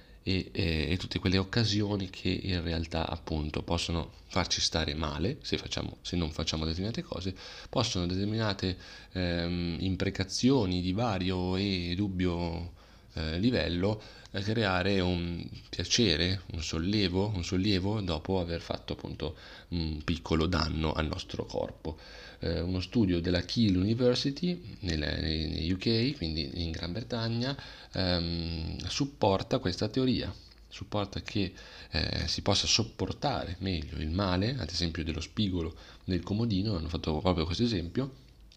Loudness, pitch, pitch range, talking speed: -31 LUFS, 90 Hz, 85-100 Hz, 130 wpm